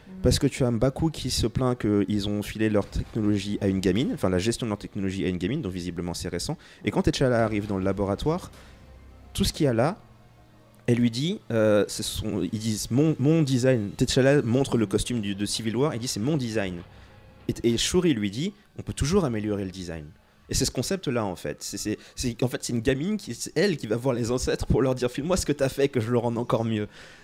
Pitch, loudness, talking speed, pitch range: 115 Hz, -26 LUFS, 250 wpm, 100-130 Hz